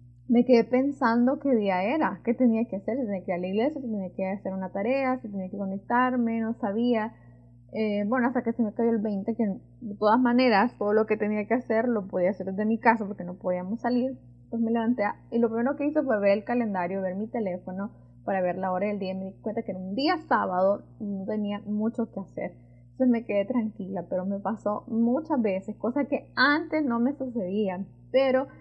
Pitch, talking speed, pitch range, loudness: 215 Hz, 230 wpm, 195-240 Hz, -27 LUFS